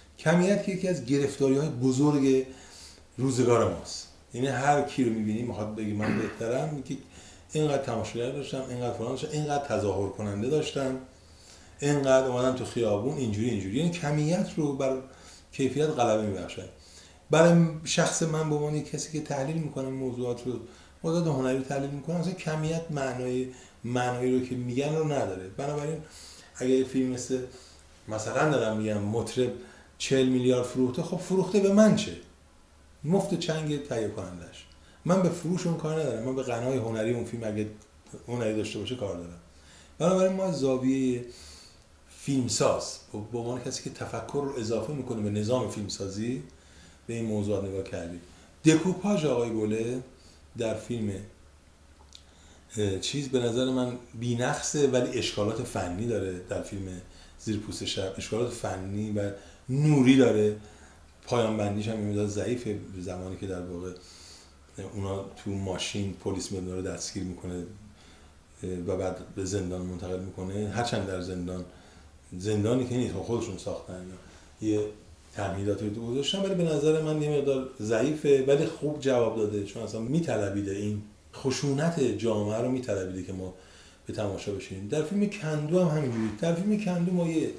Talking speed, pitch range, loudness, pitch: 145 wpm, 95-135 Hz, -29 LUFS, 115 Hz